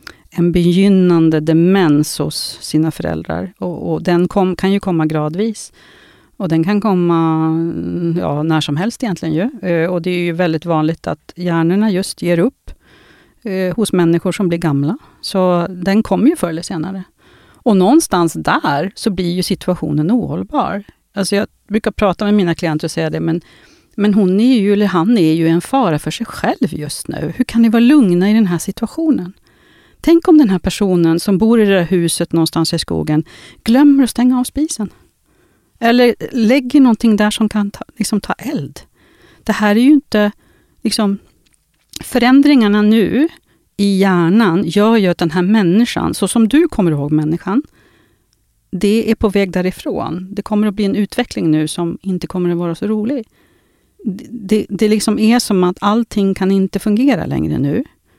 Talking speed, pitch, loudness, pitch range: 180 wpm, 195 Hz, -14 LUFS, 170-220 Hz